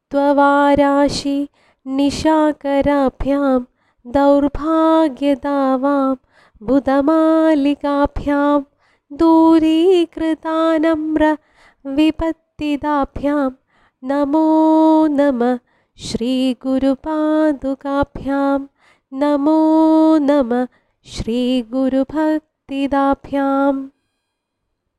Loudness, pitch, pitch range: -16 LUFS, 285 Hz, 275-310 Hz